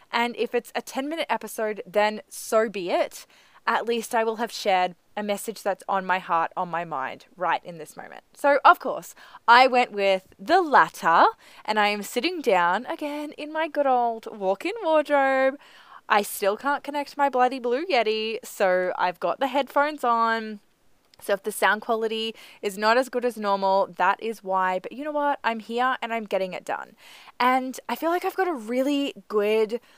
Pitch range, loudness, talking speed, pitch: 200-270 Hz, -24 LUFS, 200 wpm, 230 Hz